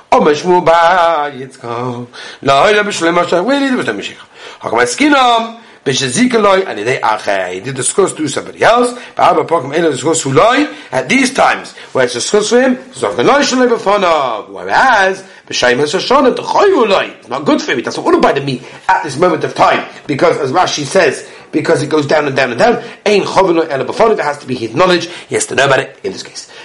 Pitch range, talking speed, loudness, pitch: 155-240 Hz, 205 wpm, -12 LUFS, 190 Hz